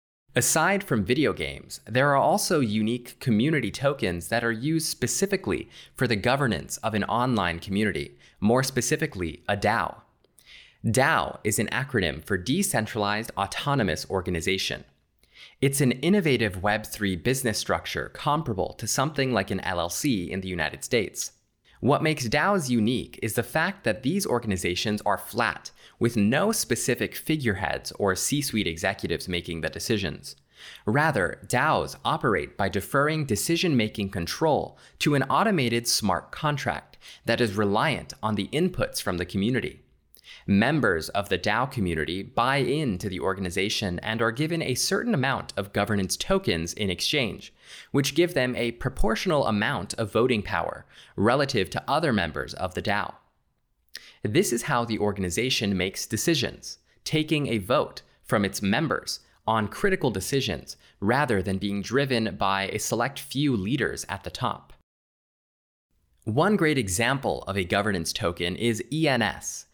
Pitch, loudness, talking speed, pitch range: 110 Hz, -26 LUFS, 145 wpm, 95-135 Hz